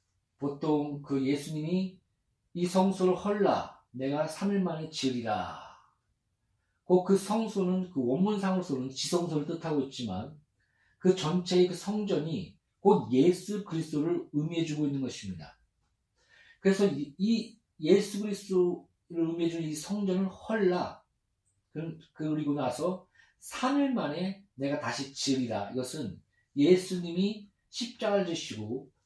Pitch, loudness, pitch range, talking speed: 165 Hz, -30 LUFS, 140-190 Hz, 255 characters per minute